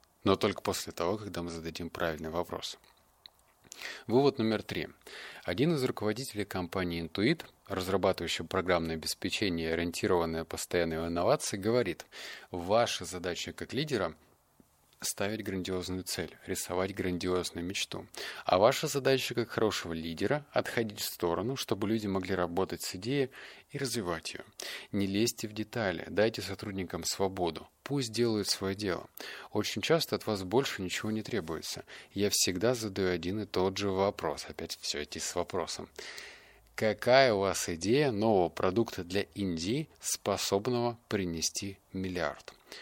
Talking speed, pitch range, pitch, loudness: 135 wpm, 90-110 Hz, 95 Hz, -32 LUFS